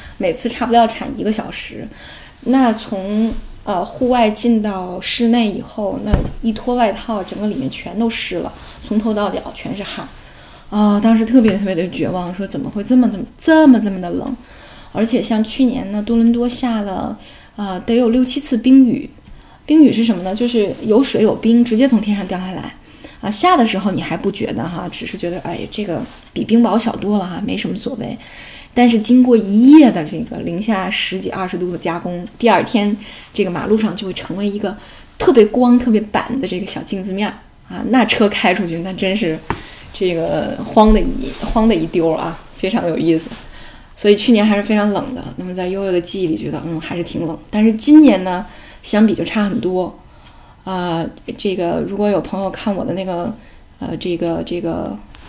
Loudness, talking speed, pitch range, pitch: -16 LUFS, 290 characters per minute, 185-235 Hz, 215 Hz